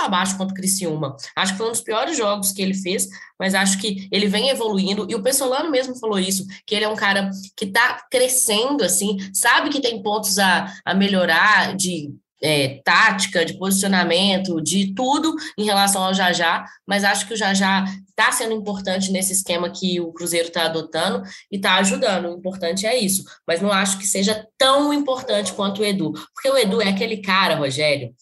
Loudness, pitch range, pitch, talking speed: -19 LUFS, 180-215 Hz, 195 Hz, 195 wpm